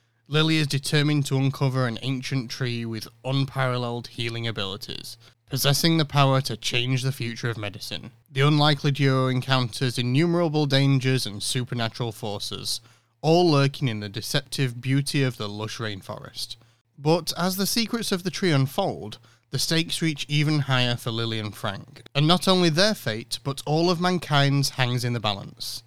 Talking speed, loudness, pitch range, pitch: 160 wpm, -24 LUFS, 115-150 Hz, 130 Hz